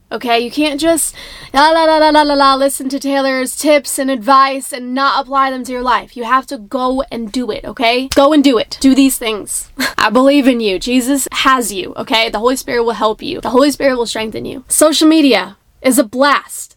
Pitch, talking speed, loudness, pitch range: 270 Hz, 230 wpm, -13 LUFS, 245-280 Hz